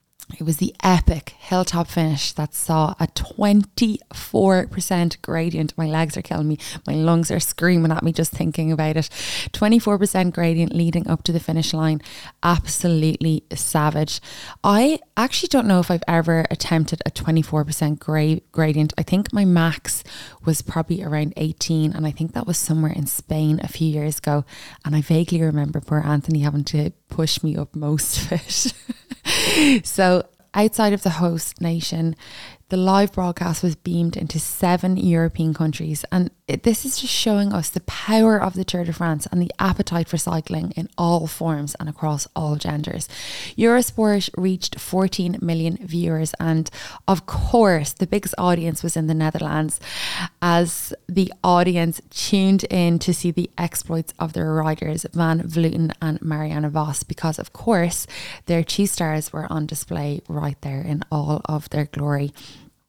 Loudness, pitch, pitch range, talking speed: -21 LUFS, 165 Hz, 155-180 Hz, 165 wpm